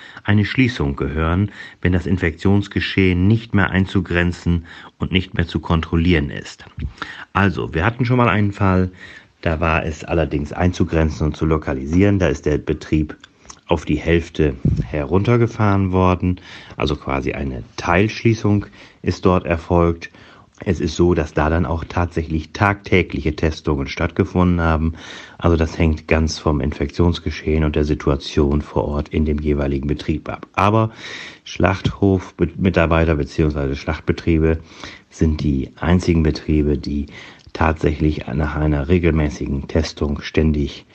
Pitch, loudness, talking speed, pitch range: 80 Hz, -19 LUFS, 130 wpm, 75-95 Hz